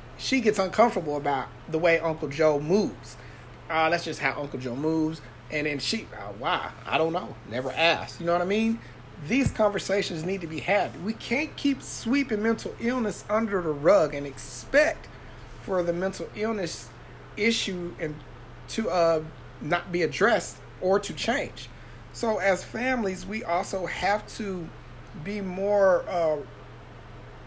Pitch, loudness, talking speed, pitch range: 175 Hz, -26 LUFS, 155 wpm, 150-205 Hz